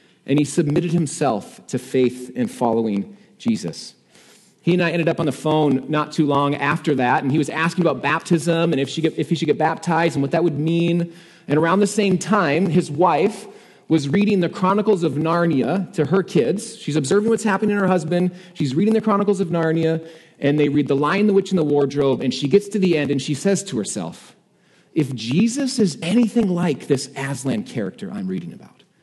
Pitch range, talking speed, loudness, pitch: 145-195 Hz, 215 wpm, -20 LUFS, 165 Hz